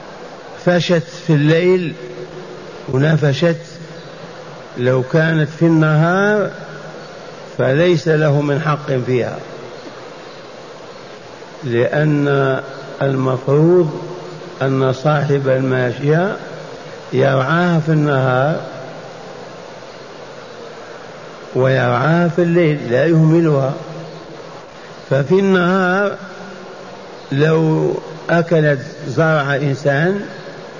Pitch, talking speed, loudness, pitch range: 160 Hz, 60 wpm, -15 LUFS, 135-175 Hz